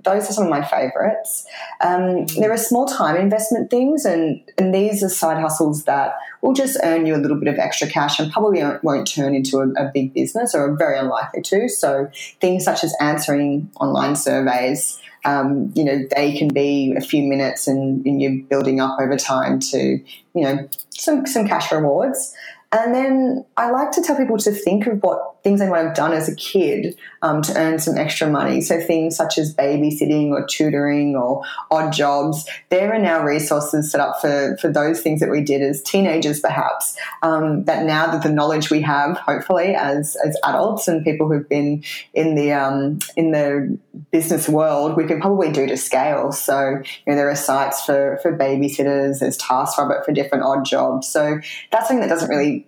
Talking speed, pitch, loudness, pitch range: 200 wpm, 155 Hz, -19 LUFS, 140-185 Hz